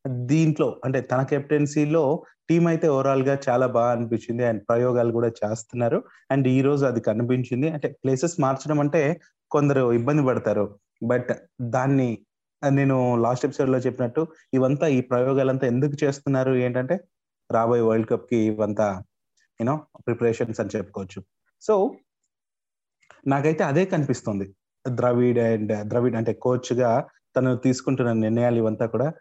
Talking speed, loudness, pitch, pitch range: 130 wpm, -23 LUFS, 125 Hz, 115-140 Hz